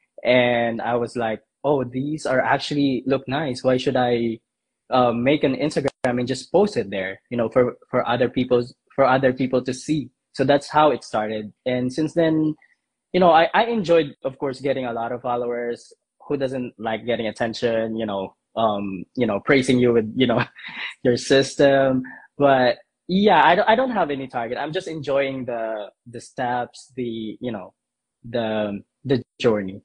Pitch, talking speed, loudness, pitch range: 125 Hz, 185 wpm, -21 LUFS, 120-140 Hz